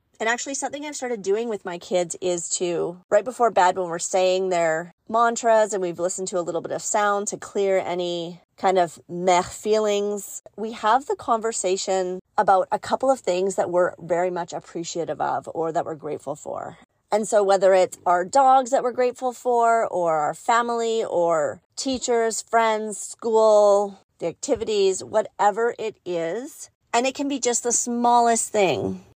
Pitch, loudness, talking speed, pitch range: 205 Hz, -22 LUFS, 175 wpm, 180-235 Hz